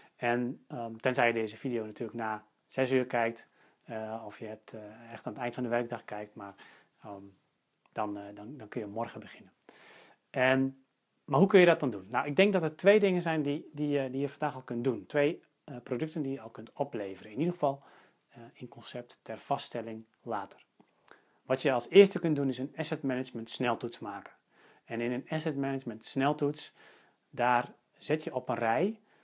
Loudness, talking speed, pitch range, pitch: -31 LUFS, 205 wpm, 115-145 Hz, 125 Hz